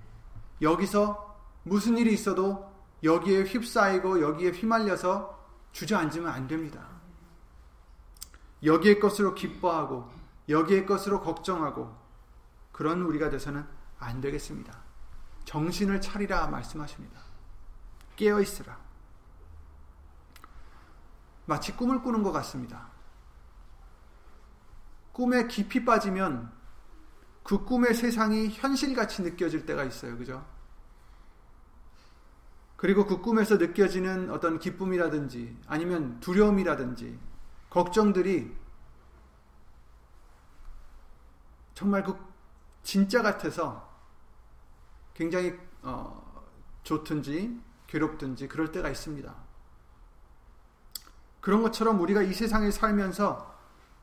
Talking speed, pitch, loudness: 220 characters per minute, 155 Hz, -28 LUFS